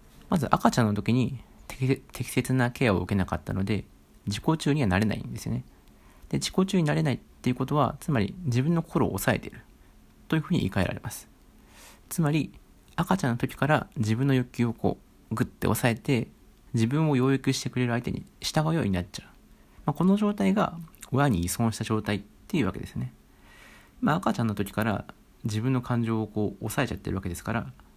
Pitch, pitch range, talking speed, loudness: 120 Hz, 105-145 Hz, 390 characters per minute, -27 LUFS